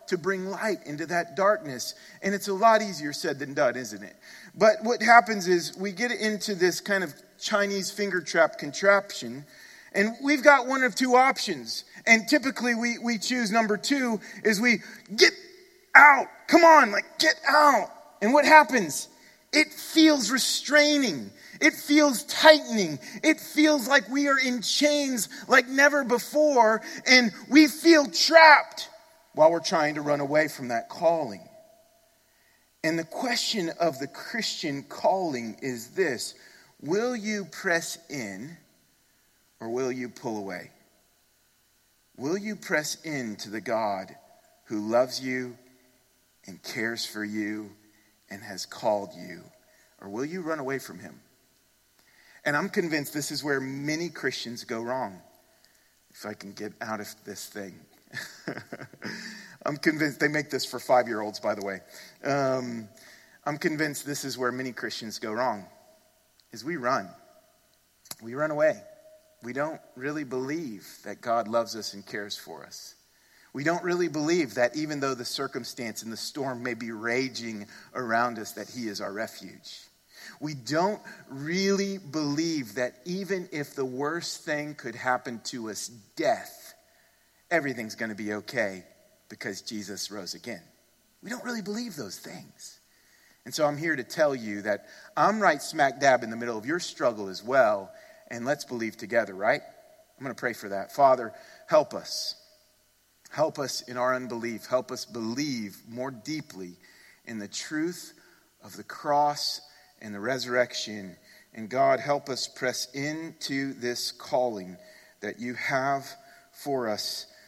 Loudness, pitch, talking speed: -25 LUFS, 155 Hz, 155 wpm